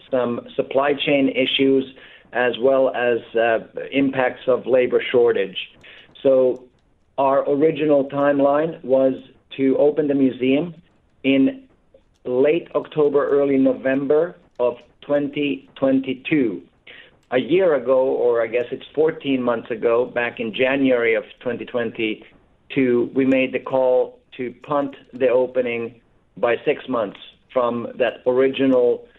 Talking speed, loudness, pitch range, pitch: 115 wpm, -20 LUFS, 125-145 Hz, 135 Hz